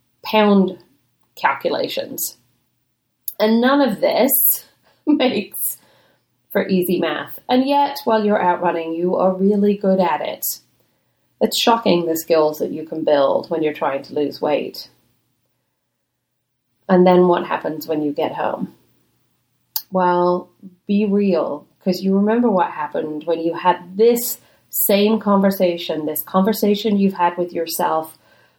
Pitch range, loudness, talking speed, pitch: 160-205 Hz, -18 LUFS, 135 wpm, 180 Hz